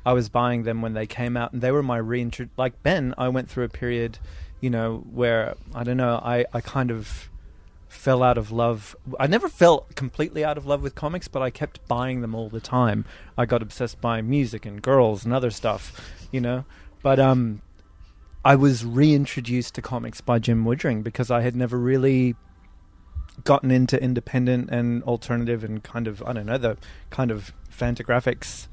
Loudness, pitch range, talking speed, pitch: -24 LUFS, 115-130 Hz, 195 wpm, 120 Hz